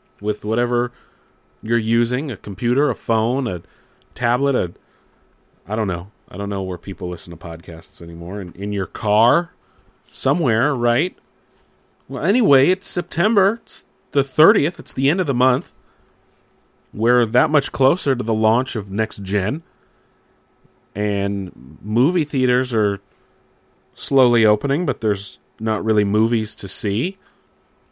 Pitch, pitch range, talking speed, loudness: 110 Hz, 100-135 Hz, 140 wpm, -19 LUFS